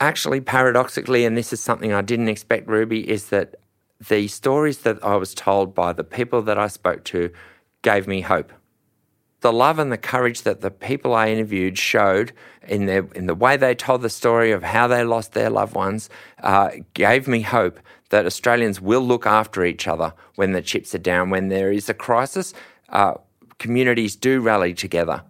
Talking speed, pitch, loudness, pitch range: 190 wpm, 110 Hz, -20 LUFS, 100-120 Hz